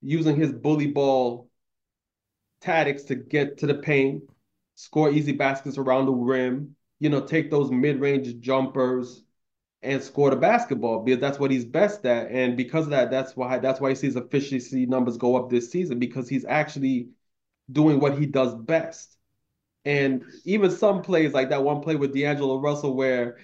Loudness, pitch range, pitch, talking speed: -24 LUFS, 130-145 Hz, 135 Hz, 175 wpm